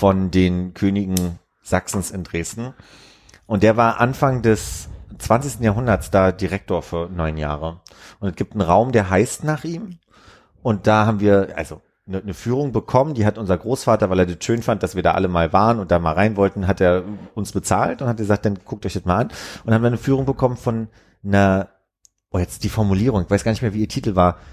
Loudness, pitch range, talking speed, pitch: -20 LUFS, 90-115 Hz, 220 wpm, 100 Hz